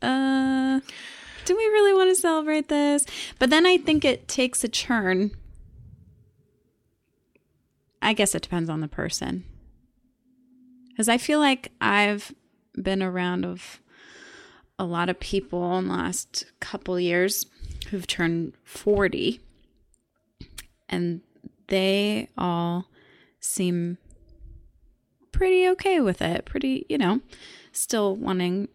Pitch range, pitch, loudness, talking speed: 175-265 Hz, 205 Hz, -24 LUFS, 115 wpm